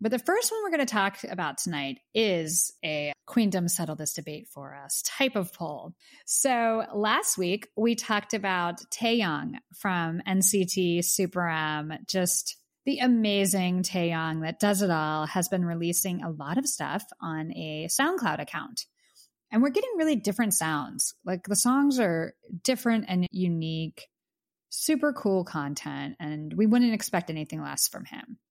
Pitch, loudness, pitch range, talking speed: 190 Hz, -27 LUFS, 165-230 Hz, 155 wpm